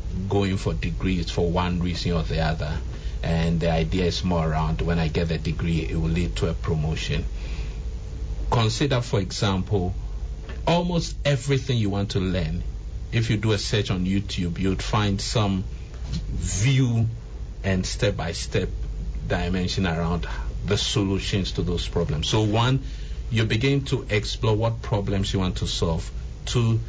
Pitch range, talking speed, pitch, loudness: 85-110 Hz, 155 wpm, 95 Hz, -25 LUFS